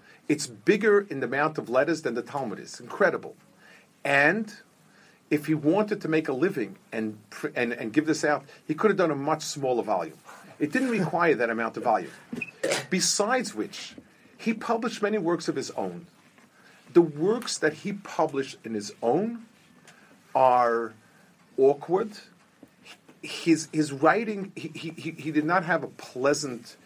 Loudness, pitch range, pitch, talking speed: -26 LUFS, 145-205 Hz, 165 Hz, 160 wpm